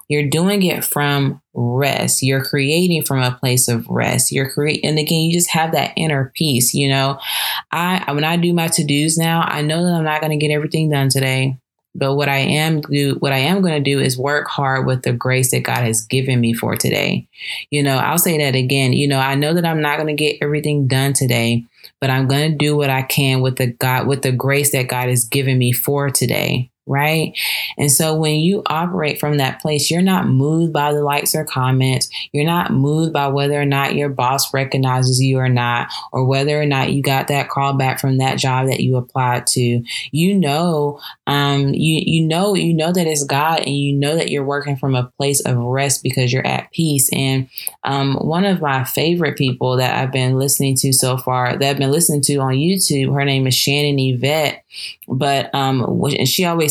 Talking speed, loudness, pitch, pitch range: 220 wpm, -16 LUFS, 140 Hz, 130-150 Hz